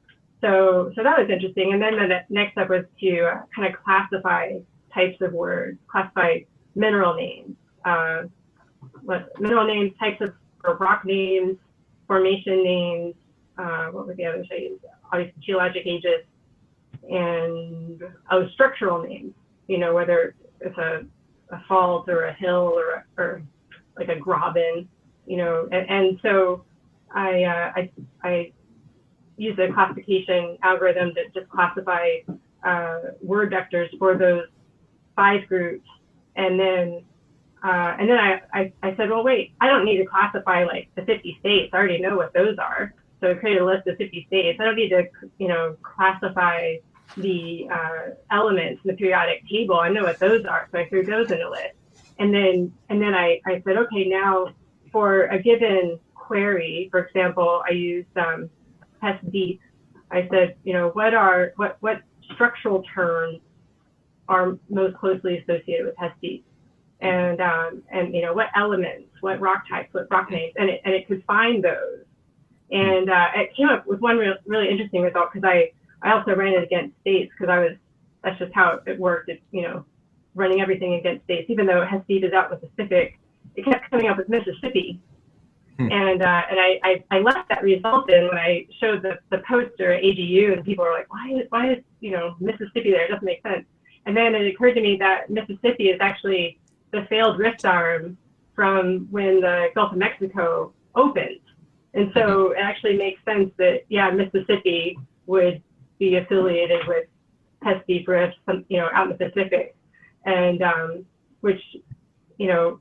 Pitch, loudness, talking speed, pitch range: 185 Hz, -22 LUFS, 175 wpm, 175-200 Hz